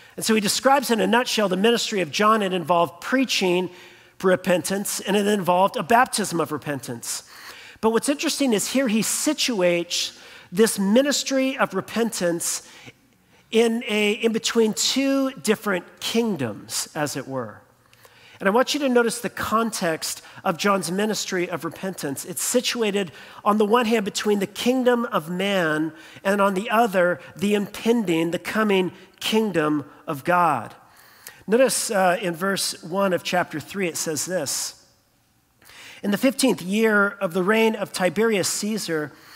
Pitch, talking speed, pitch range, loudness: 200 Hz, 150 wpm, 175-230 Hz, -22 LUFS